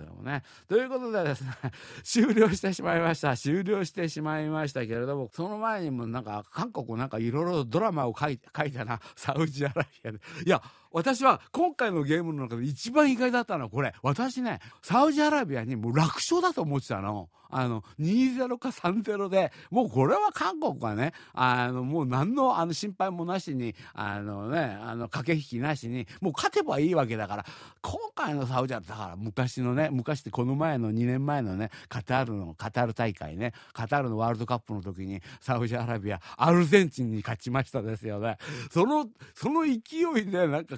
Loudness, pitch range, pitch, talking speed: -29 LUFS, 120-185 Hz, 140 Hz, 375 characters per minute